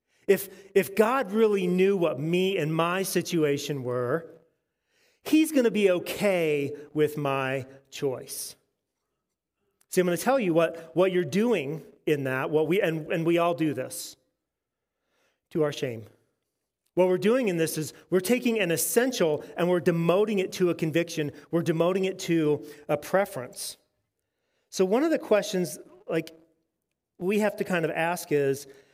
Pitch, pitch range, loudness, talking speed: 170 Hz, 155-195 Hz, -26 LUFS, 160 wpm